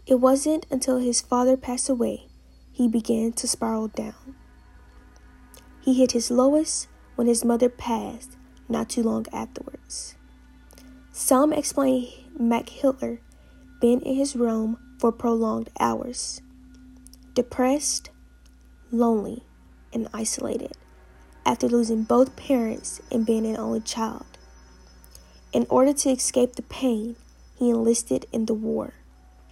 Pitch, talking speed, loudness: 235 Hz, 120 wpm, -24 LUFS